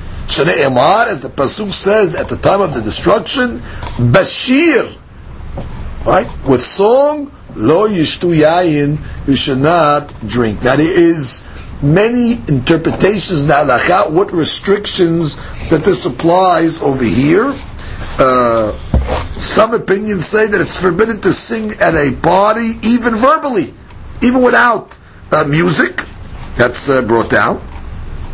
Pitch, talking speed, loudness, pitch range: 170 Hz, 115 wpm, -11 LUFS, 135-215 Hz